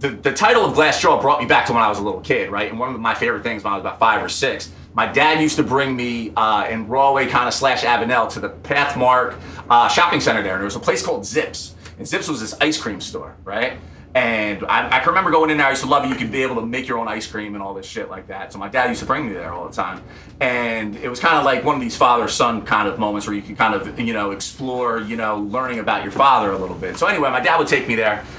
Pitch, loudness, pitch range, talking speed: 120 Hz, -18 LUFS, 105-130 Hz, 300 wpm